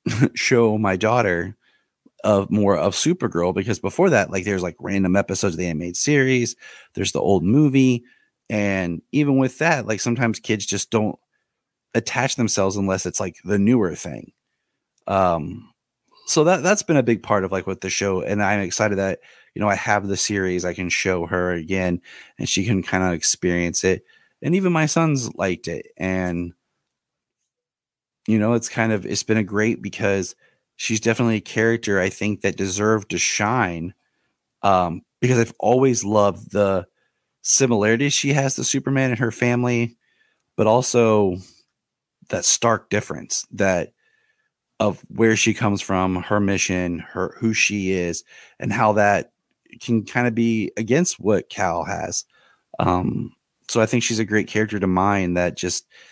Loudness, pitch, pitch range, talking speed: -20 LUFS, 105 Hz, 95-120 Hz, 165 wpm